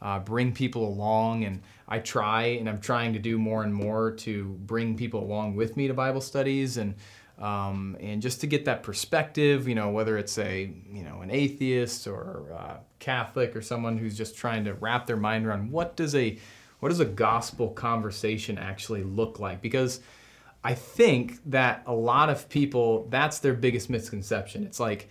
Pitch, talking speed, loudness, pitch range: 115 Hz, 190 wpm, -28 LUFS, 105-125 Hz